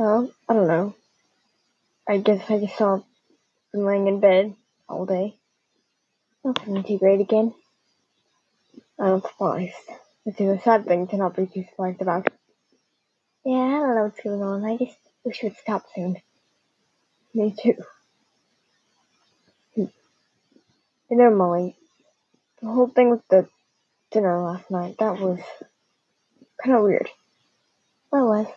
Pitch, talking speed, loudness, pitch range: 205 Hz, 135 wpm, -23 LUFS, 190-230 Hz